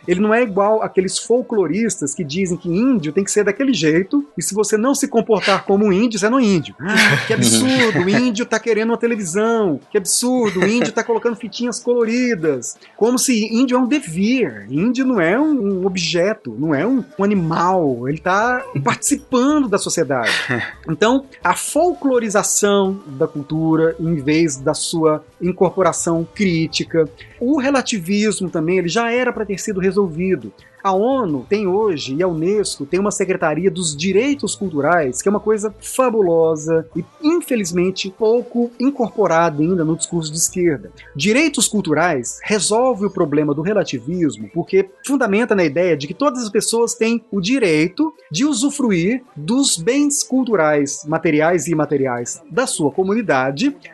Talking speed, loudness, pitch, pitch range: 160 wpm, -17 LUFS, 200 Hz, 165-235 Hz